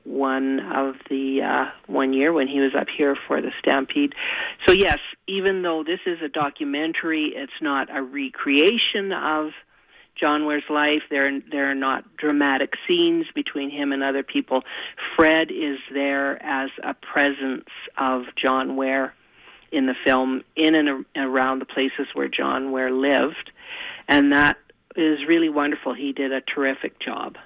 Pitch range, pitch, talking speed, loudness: 135-155 Hz, 140 Hz, 155 wpm, -22 LUFS